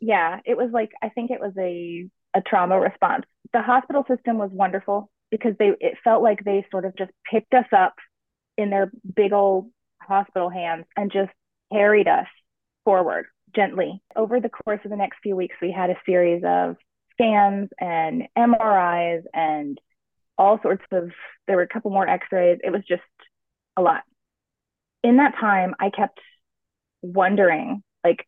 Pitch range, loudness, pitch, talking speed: 180-230 Hz, -22 LUFS, 200 Hz, 170 wpm